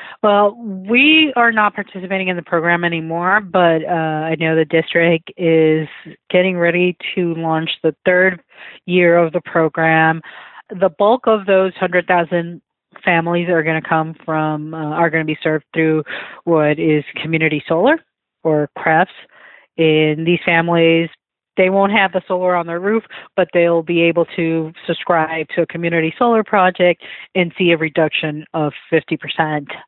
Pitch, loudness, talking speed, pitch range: 170 Hz, -16 LUFS, 155 wpm, 160-185 Hz